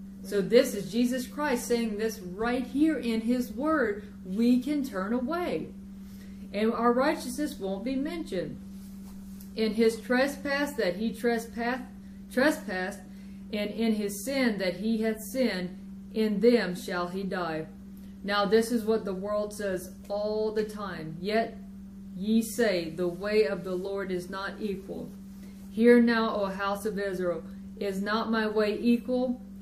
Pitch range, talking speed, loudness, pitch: 195-235 Hz, 150 wpm, -29 LUFS, 210 Hz